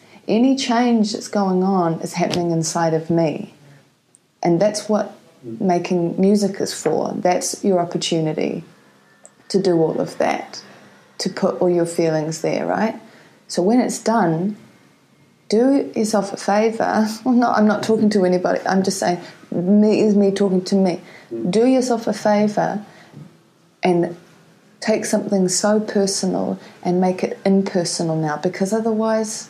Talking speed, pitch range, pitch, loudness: 145 wpm, 175-215 Hz, 195 Hz, -19 LUFS